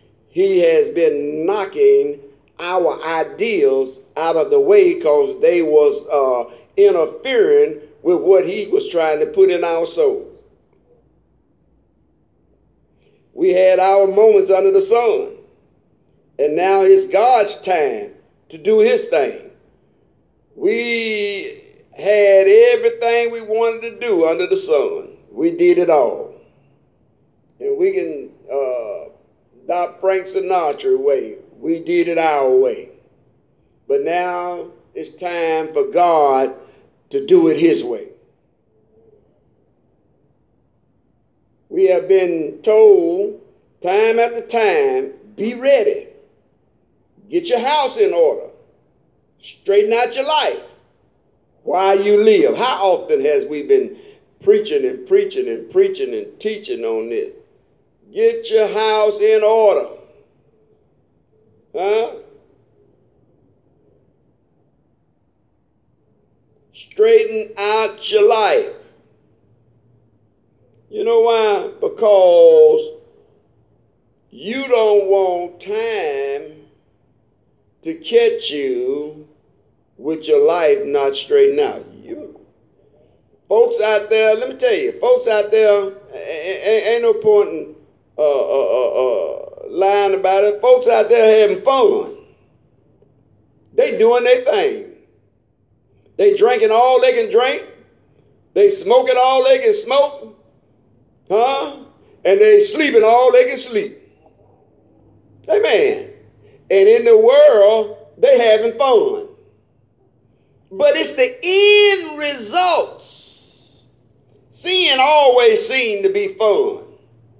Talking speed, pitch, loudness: 110 wpm, 400 Hz, -15 LUFS